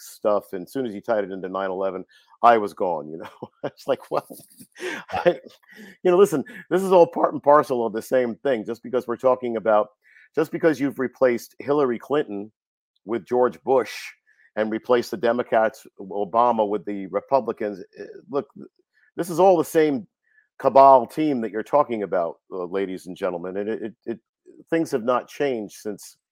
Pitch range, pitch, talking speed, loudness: 110-165 Hz, 125 Hz, 180 wpm, -22 LUFS